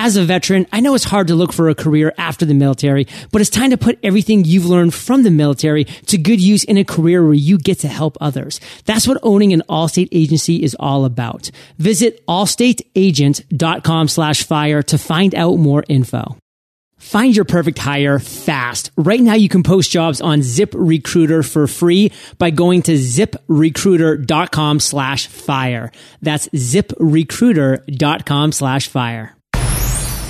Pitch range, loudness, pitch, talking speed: 145-190 Hz, -14 LUFS, 160 Hz, 160 wpm